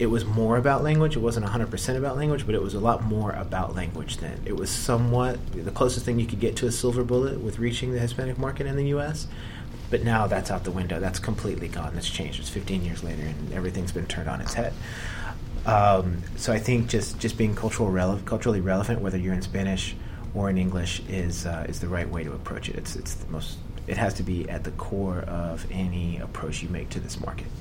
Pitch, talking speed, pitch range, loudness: 100 Hz, 235 wpm, 90-115 Hz, -27 LUFS